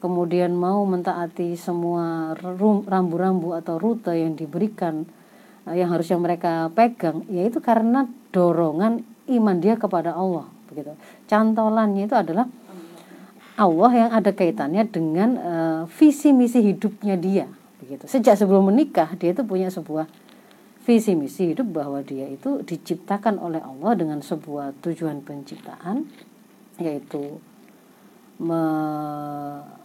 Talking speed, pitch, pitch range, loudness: 115 wpm, 180 Hz, 165-220 Hz, -22 LUFS